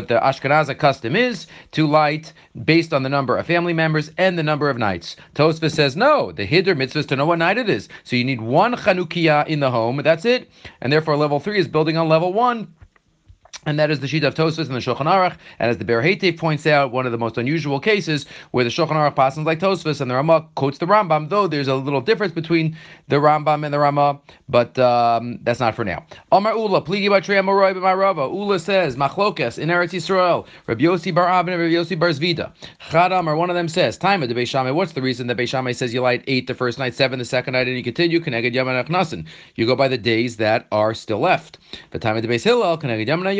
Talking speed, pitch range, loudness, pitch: 230 wpm, 130-175 Hz, -19 LUFS, 150 Hz